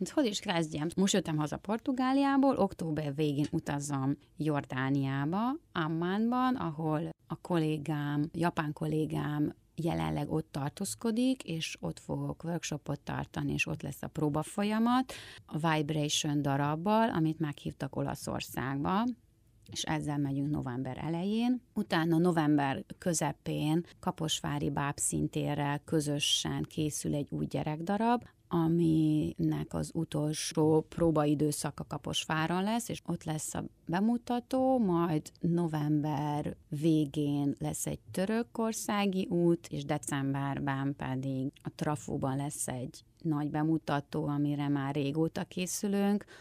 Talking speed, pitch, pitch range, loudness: 110 wpm, 155 Hz, 145-180 Hz, -32 LUFS